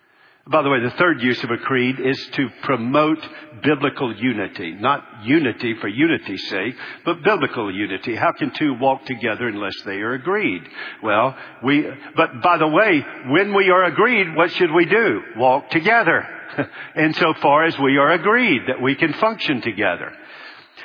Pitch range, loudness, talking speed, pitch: 130-175 Hz, -19 LUFS, 170 wpm, 150 Hz